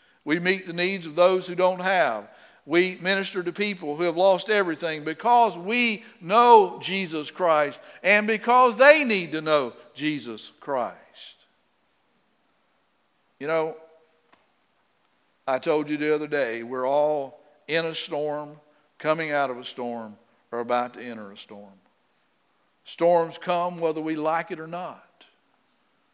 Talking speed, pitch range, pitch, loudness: 140 wpm, 150-185 Hz, 160 Hz, -23 LUFS